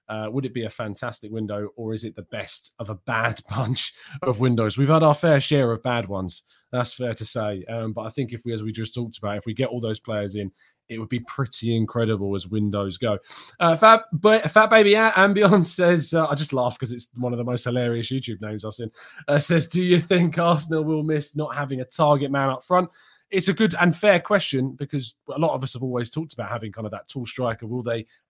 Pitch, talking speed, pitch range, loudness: 125 Hz, 250 wpm, 110-155 Hz, -22 LUFS